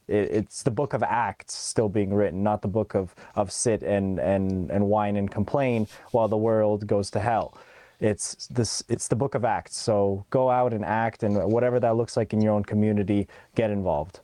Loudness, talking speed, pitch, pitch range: -25 LUFS, 205 wpm, 105 Hz, 100-115 Hz